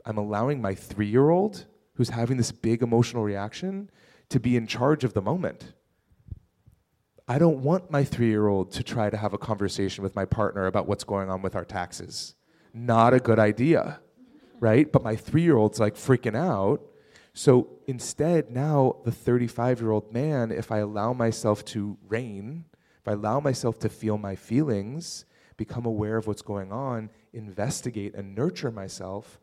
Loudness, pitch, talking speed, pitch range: -26 LUFS, 115 Hz, 175 wpm, 105-130 Hz